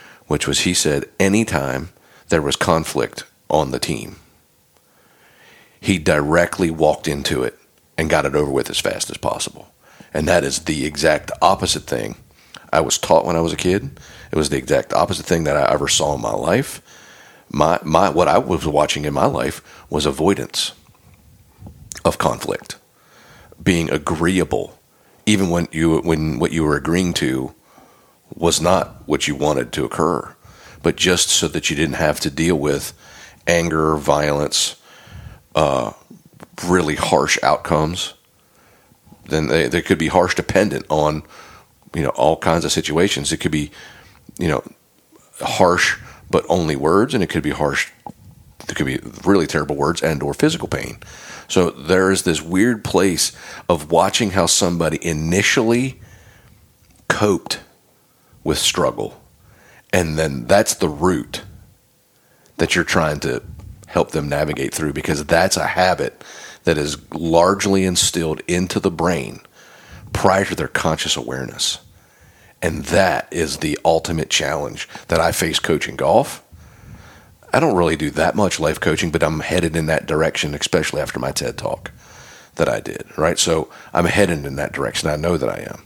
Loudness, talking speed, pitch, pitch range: -18 LUFS, 160 wpm, 85 Hz, 75-90 Hz